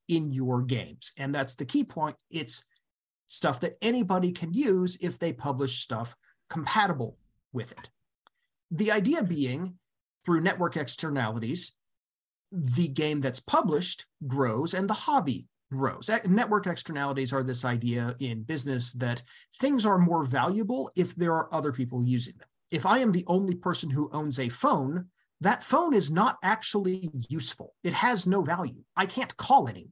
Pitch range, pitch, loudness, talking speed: 130-185 Hz, 160 Hz, -27 LUFS, 160 wpm